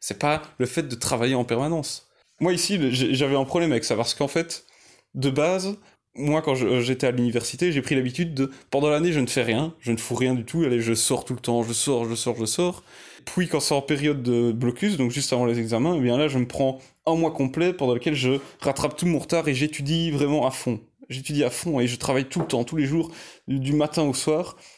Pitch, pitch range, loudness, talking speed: 140 Hz, 125-155 Hz, -24 LUFS, 250 wpm